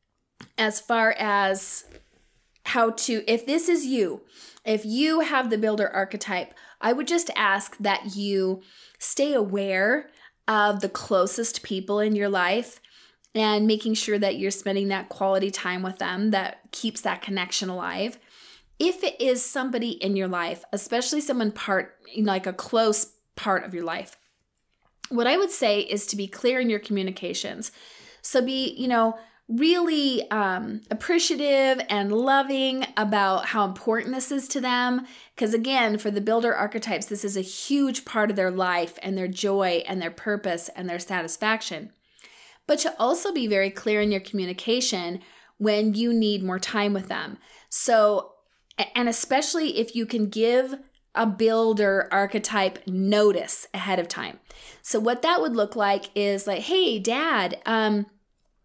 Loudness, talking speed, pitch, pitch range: -24 LUFS, 160 wpm, 215 Hz, 195-240 Hz